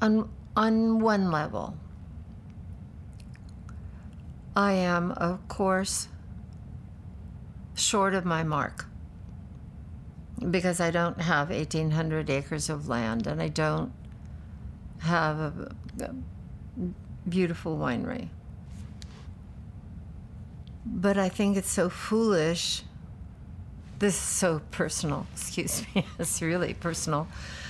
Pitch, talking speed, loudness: 145 Hz, 95 wpm, -28 LUFS